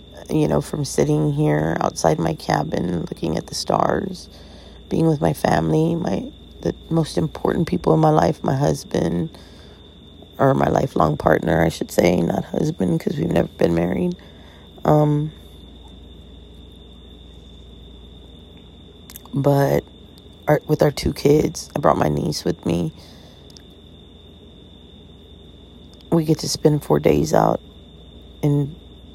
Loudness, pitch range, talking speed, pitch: -20 LUFS, 80-90 Hz, 125 wpm, 80 Hz